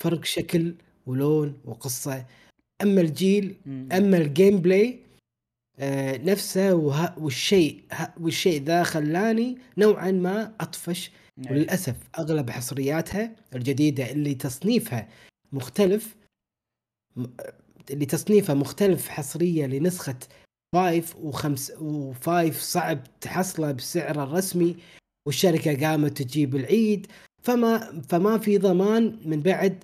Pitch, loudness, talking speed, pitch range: 165 Hz, -24 LUFS, 90 wpm, 140-190 Hz